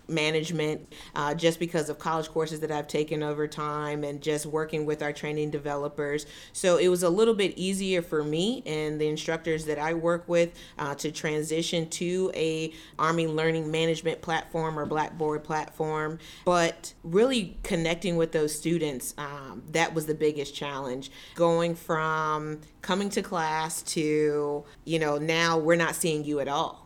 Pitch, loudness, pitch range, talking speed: 155 Hz, -28 LUFS, 150-165 Hz, 165 wpm